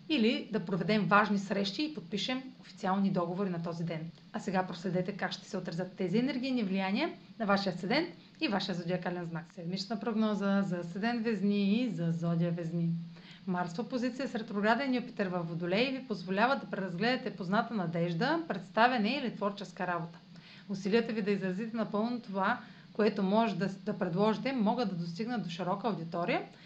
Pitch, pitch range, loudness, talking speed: 200 Hz, 180-230 Hz, -33 LUFS, 160 wpm